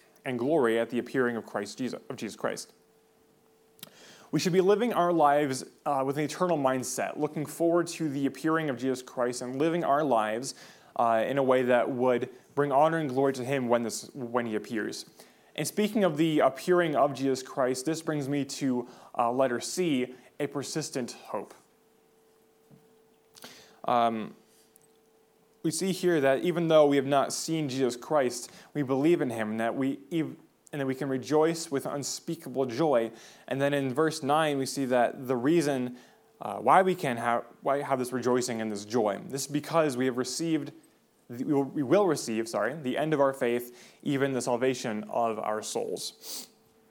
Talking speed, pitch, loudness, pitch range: 180 wpm, 135 Hz, -28 LUFS, 125-155 Hz